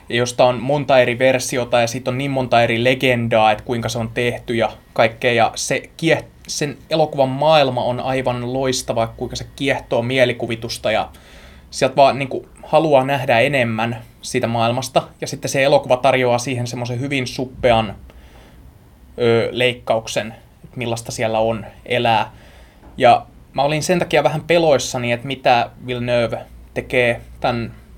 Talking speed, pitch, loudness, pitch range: 150 wpm, 125 Hz, -18 LUFS, 115-135 Hz